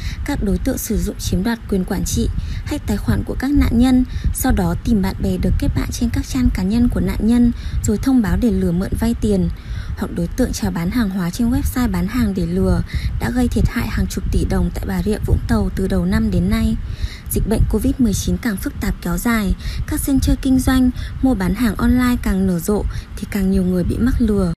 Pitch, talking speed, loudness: 190 Hz, 240 wpm, -19 LUFS